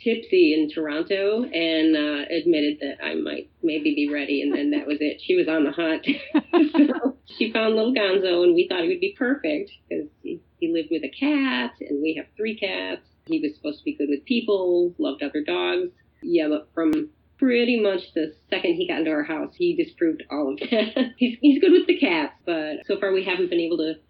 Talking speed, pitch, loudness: 220 wpm, 200 Hz, -23 LUFS